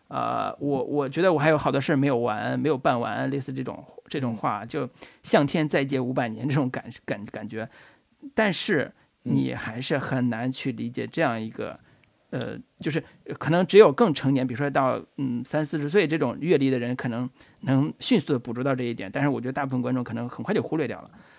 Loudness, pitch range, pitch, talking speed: -25 LUFS, 125-145 Hz, 135 Hz, 305 characters per minute